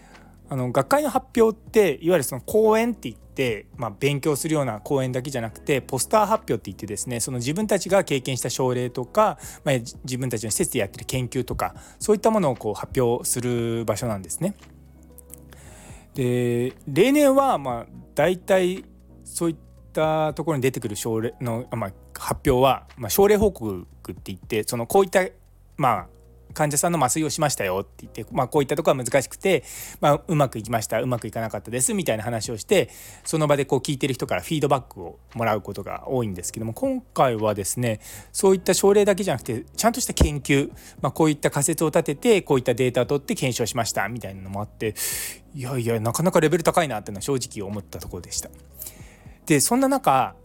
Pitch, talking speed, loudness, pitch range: 130 Hz, 430 characters per minute, -23 LUFS, 115-160 Hz